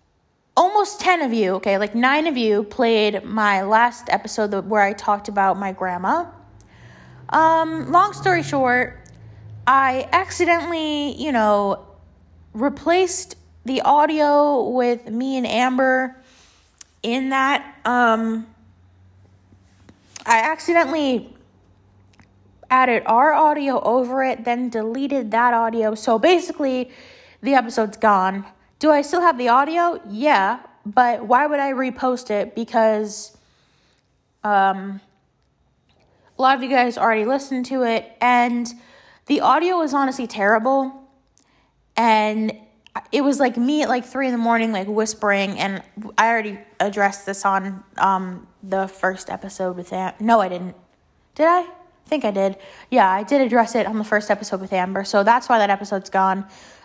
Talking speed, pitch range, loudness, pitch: 140 wpm, 195-270 Hz, -19 LUFS, 230 Hz